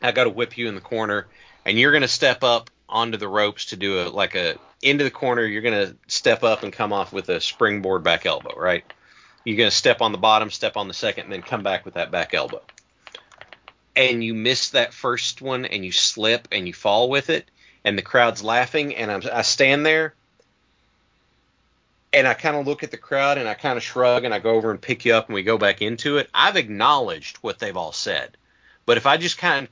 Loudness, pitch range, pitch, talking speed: -20 LUFS, 110-135 Hz, 120 Hz, 240 wpm